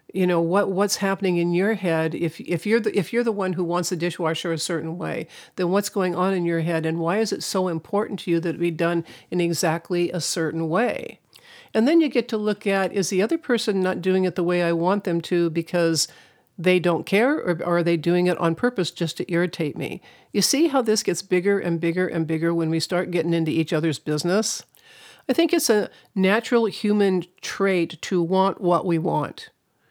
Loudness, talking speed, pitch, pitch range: -23 LUFS, 225 wpm, 180 Hz, 170-200 Hz